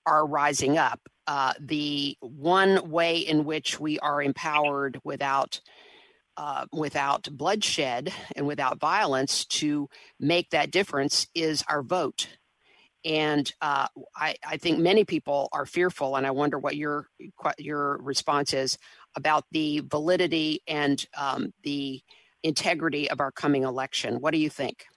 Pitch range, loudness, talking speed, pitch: 140-160 Hz, -27 LUFS, 140 wpm, 150 Hz